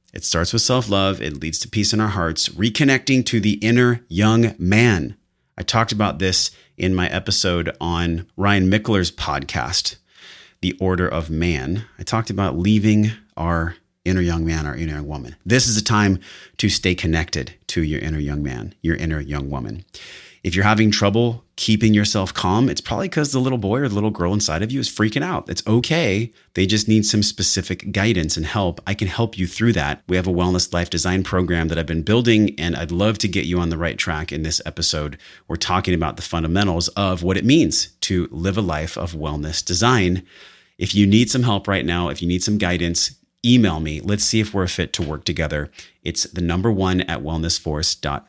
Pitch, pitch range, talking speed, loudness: 90 Hz, 85-105 Hz, 210 wpm, -20 LUFS